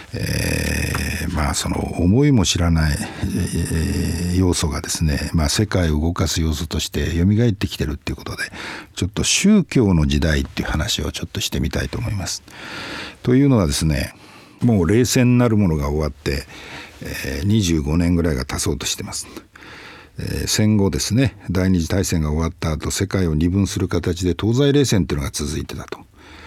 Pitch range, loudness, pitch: 80-100 Hz, -20 LUFS, 90 Hz